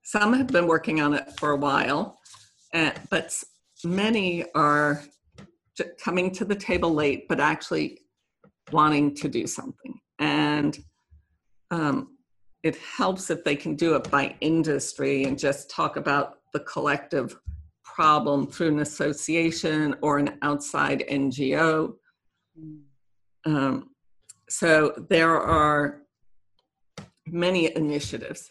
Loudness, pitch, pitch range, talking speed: -25 LUFS, 150 Hz, 140-165 Hz, 115 wpm